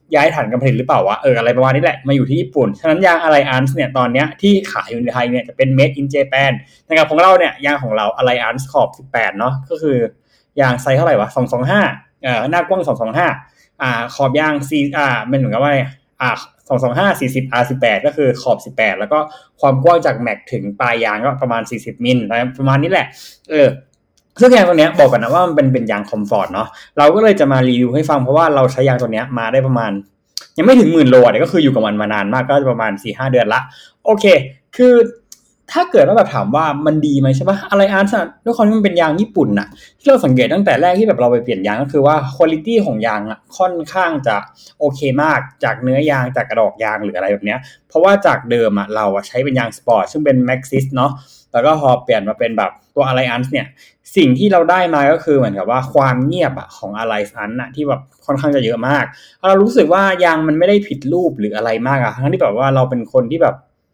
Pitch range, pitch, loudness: 125-160 Hz, 135 Hz, -14 LUFS